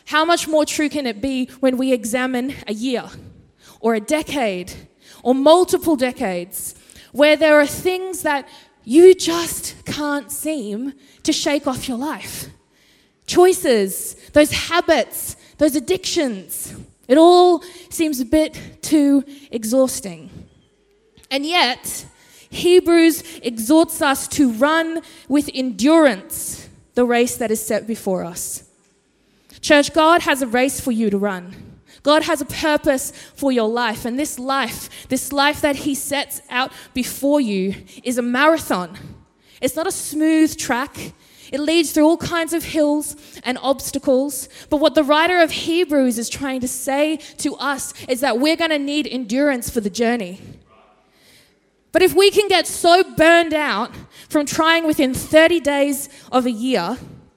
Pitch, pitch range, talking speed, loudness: 290 Hz, 255-315 Hz, 150 wpm, -18 LUFS